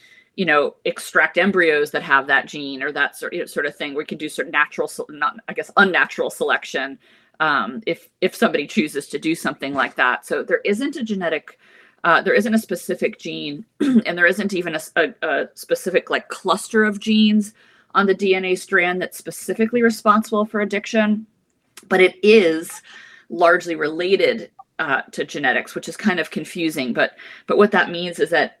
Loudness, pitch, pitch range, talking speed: -19 LUFS, 200 Hz, 175-230 Hz, 185 wpm